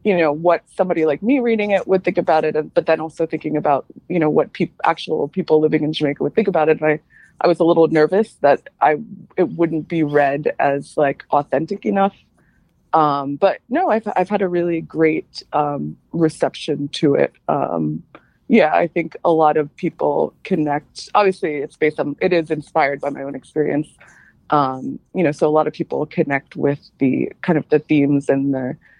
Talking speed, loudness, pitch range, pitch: 200 wpm, -19 LUFS, 145-175 Hz, 155 Hz